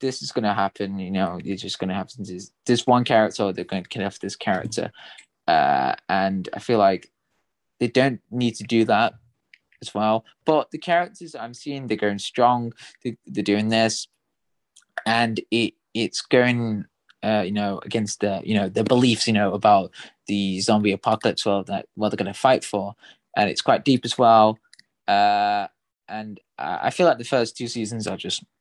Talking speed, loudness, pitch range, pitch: 195 wpm, -22 LUFS, 100-120 Hz, 110 Hz